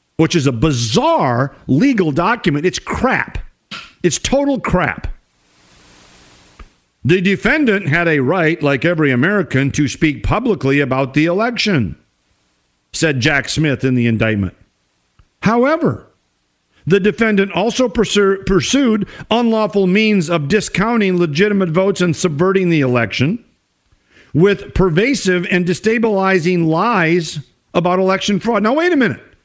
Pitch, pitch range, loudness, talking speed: 175 Hz, 135-205 Hz, -15 LUFS, 120 wpm